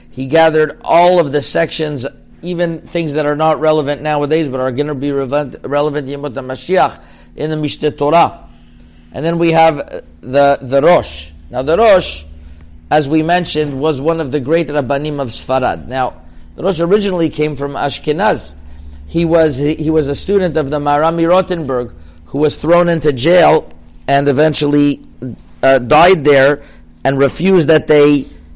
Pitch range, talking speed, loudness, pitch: 130-160 Hz, 165 wpm, -13 LUFS, 145 Hz